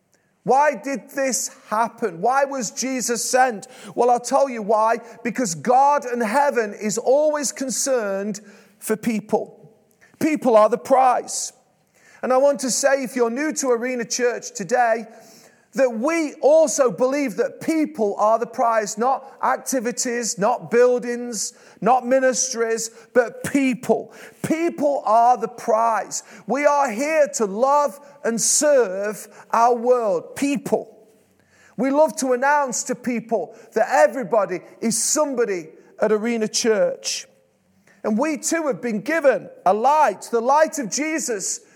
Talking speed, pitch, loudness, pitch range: 135 wpm, 245 Hz, -20 LUFS, 225-275 Hz